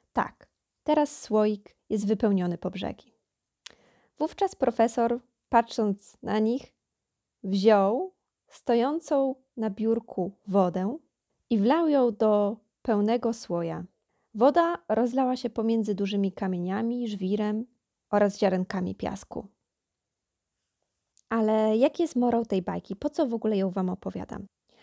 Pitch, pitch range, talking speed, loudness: 220 Hz, 195-245 Hz, 110 wpm, -27 LUFS